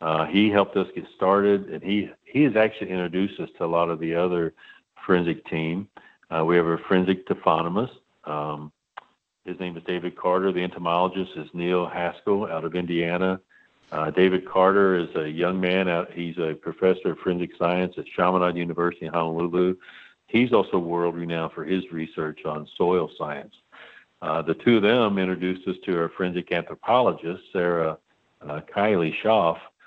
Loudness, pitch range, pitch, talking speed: -24 LUFS, 85-95 Hz, 90 Hz, 170 wpm